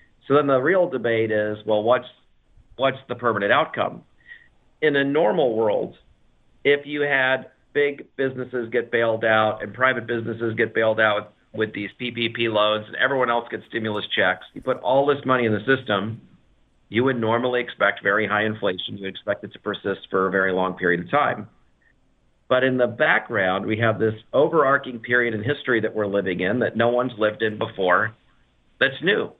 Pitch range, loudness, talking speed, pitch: 105-130 Hz, -22 LUFS, 185 wpm, 115 Hz